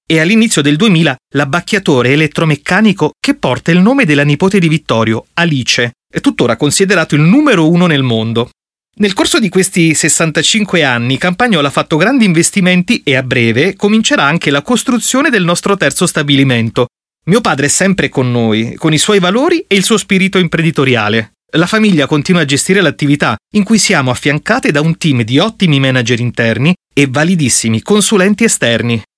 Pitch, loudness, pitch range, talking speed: 160 Hz, -10 LUFS, 140-200 Hz, 165 wpm